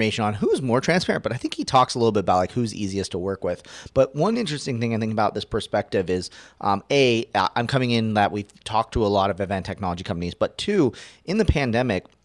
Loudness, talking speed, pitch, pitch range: -23 LUFS, 240 wpm, 110 Hz, 100-125 Hz